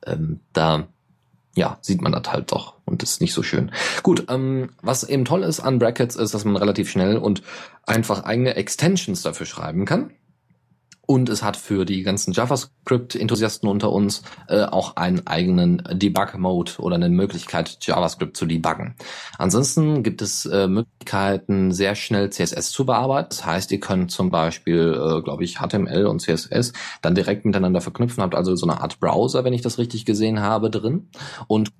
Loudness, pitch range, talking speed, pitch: -21 LUFS, 100-130 Hz, 175 wpm, 110 Hz